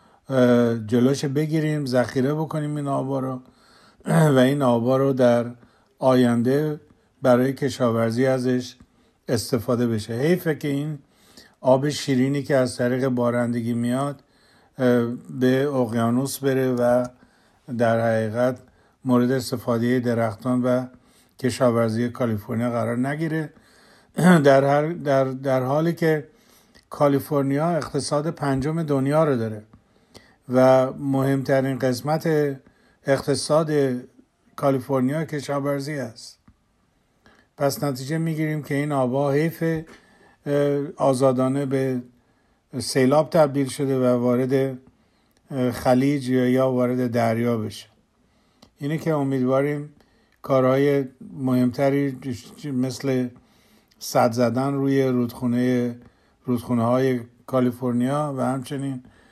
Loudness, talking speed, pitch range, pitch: -22 LUFS, 95 wpm, 125-140 Hz, 130 Hz